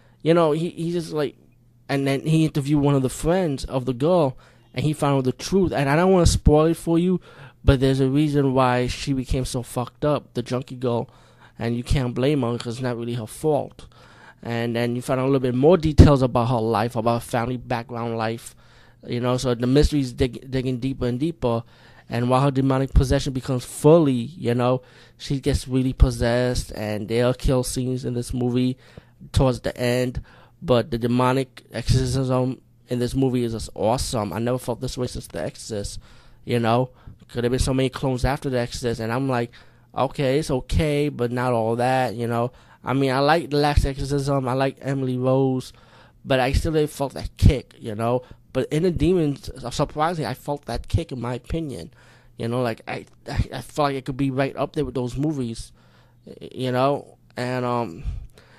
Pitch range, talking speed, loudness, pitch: 120-140 Hz, 210 wpm, -23 LUFS, 130 Hz